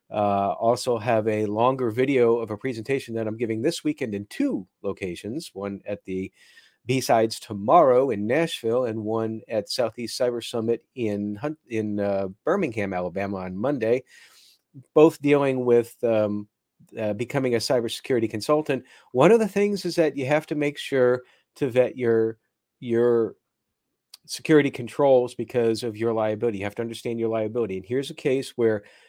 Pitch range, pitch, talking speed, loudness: 110-135 Hz, 115 Hz, 160 wpm, -24 LUFS